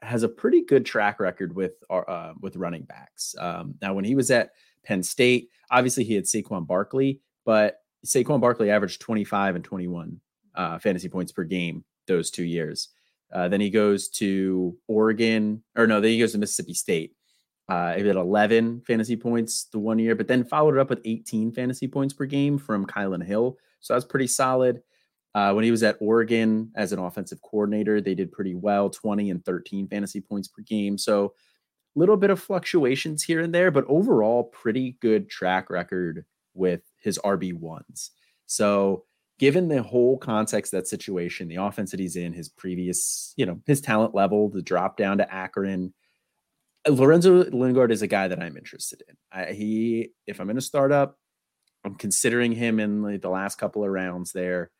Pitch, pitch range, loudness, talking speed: 105 Hz, 95-120 Hz, -24 LUFS, 190 wpm